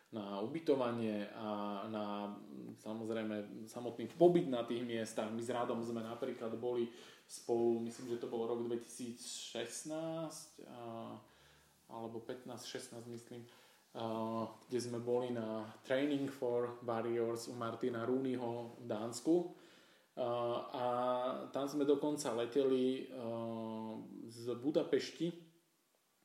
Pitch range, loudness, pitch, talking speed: 115-125 Hz, -40 LUFS, 120 Hz, 105 wpm